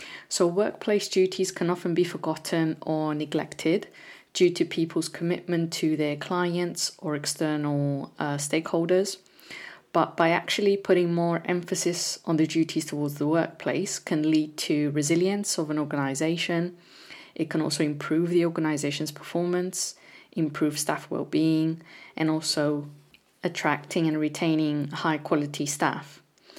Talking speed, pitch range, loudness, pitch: 125 wpm, 155-175 Hz, -27 LUFS, 165 Hz